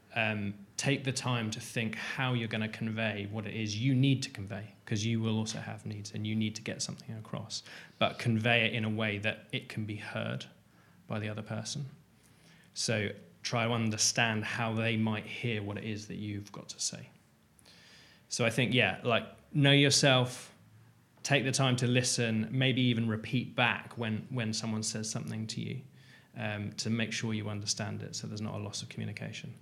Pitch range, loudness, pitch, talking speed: 110-125 Hz, -32 LUFS, 110 Hz, 200 wpm